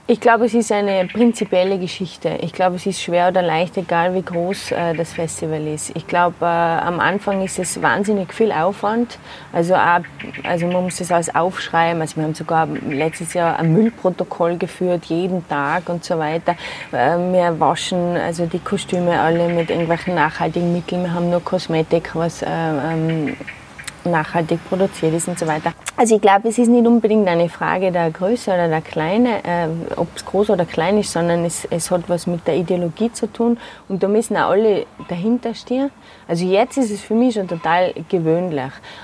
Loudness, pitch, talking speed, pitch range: -18 LUFS, 175 Hz, 190 wpm, 170-195 Hz